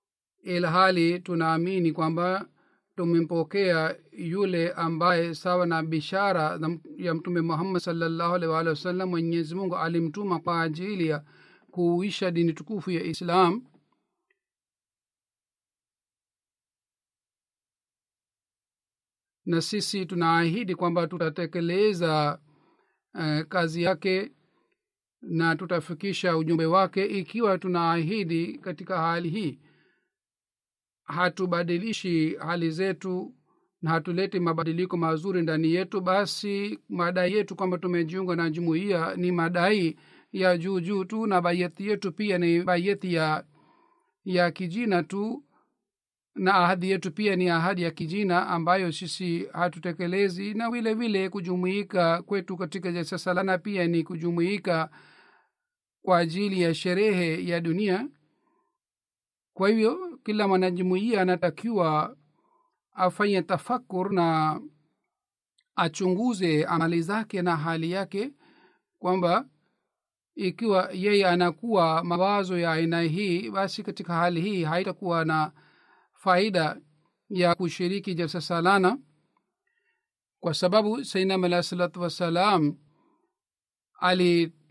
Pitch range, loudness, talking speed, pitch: 165-195 Hz, -26 LUFS, 100 wpm, 180 Hz